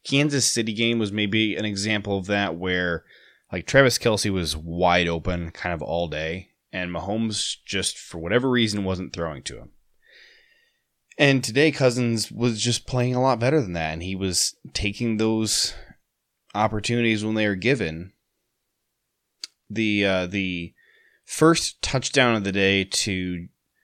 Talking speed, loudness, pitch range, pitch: 150 wpm, -23 LUFS, 90-120 Hz, 105 Hz